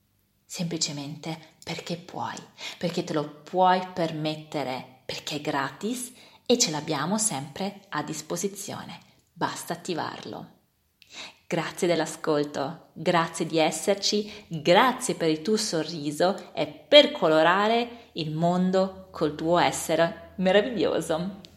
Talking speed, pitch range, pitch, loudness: 105 wpm, 155-195 Hz, 165 Hz, -26 LUFS